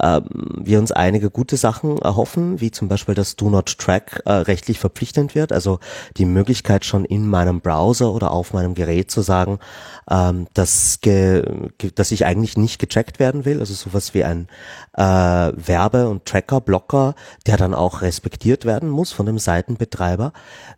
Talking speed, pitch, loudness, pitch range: 165 wpm, 100 Hz, -18 LUFS, 90-115 Hz